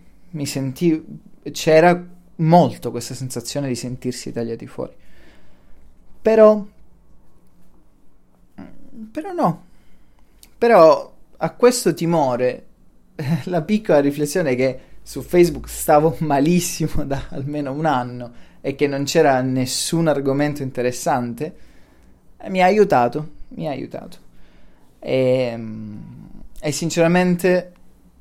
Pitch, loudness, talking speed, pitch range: 150 Hz, -19 LUFS, 100 wpm, 125-175 Hz